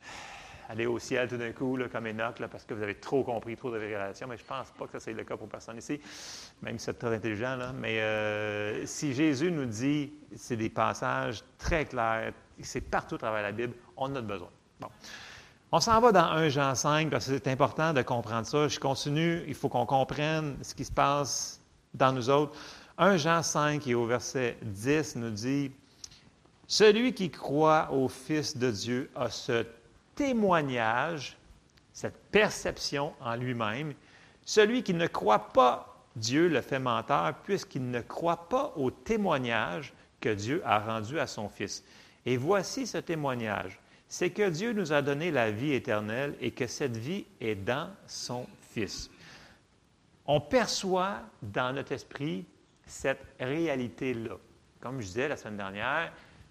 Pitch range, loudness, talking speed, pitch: 115-155 Hz, -30 LUFS, 175 wpm, 130 Hz